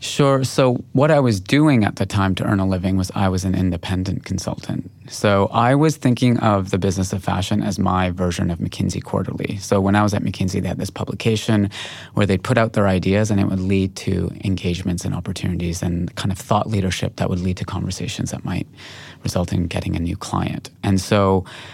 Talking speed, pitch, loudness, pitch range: 215 wpm, 95 Hz, -20 LUFS, 95-105 Hz